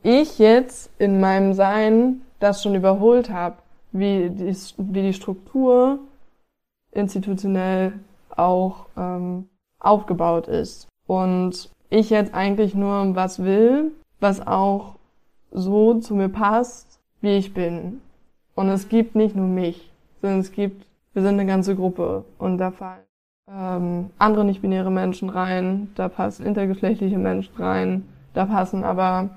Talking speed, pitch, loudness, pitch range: 130 wpm, 195 Hz, -21 LUFS, 185-205 Hz